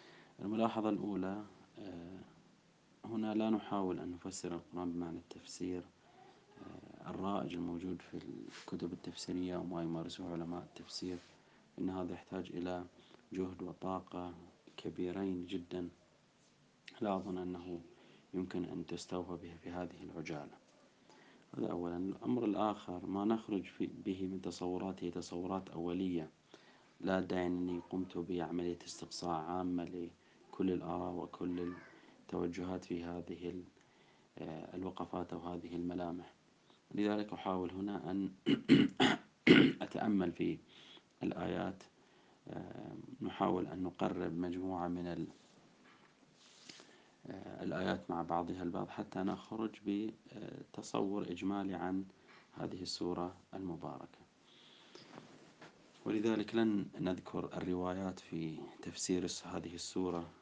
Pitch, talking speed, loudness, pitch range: 90 Hz, 100 wpm, -40 LUFS, 85-95 Hz